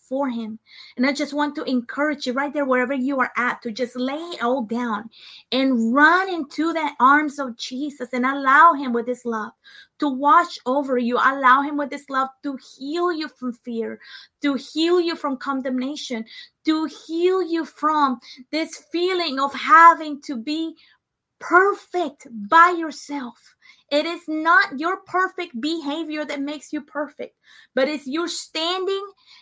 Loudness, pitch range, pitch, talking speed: -21 LUFS, 260-325 Hz, 290 Hz, 165 wpm